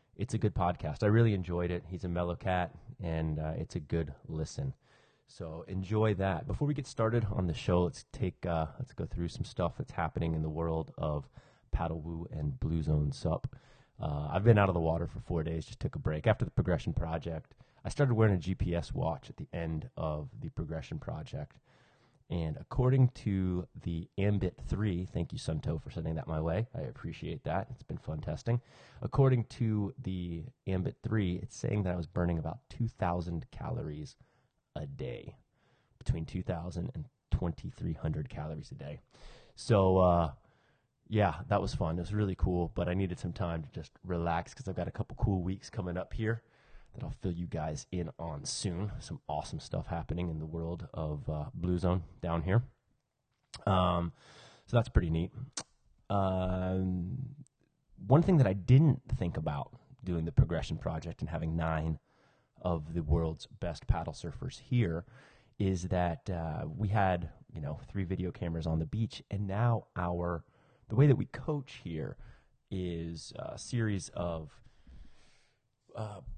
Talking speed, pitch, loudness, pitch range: 180 wpm, 95 Hz, -34 LUFS, 85-115 Hz